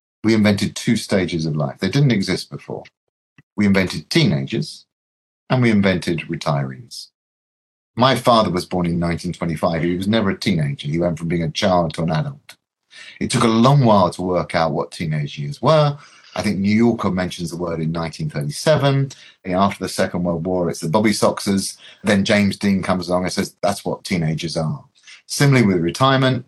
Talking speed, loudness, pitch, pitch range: 185 wpm, -19 LUFS, 100 Hz, 85-130 Hz